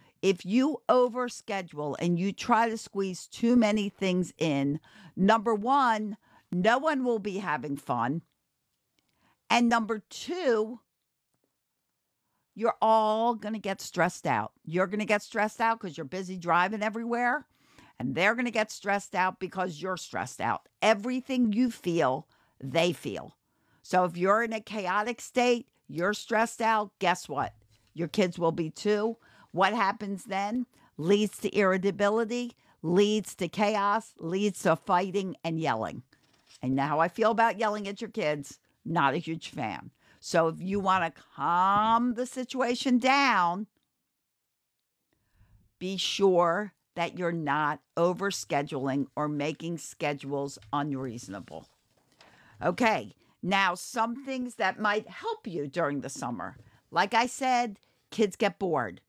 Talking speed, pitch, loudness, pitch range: 140 wpm, 195 Hz, -28 LUFS, 165-225 Hz